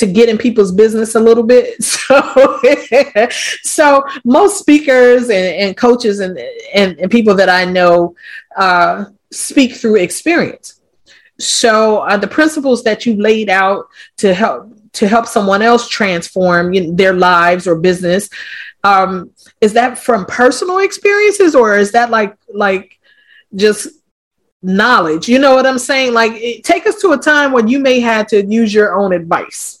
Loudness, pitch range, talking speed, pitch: -11 LUFS, 195-260 Hz, 165 wpm, 225 Hz